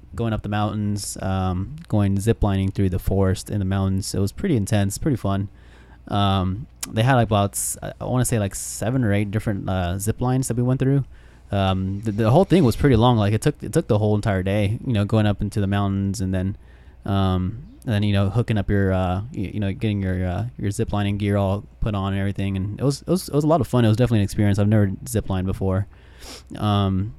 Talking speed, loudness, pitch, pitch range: 240 wpm, -22 LUFS, 100 Hz, 95-115 Hz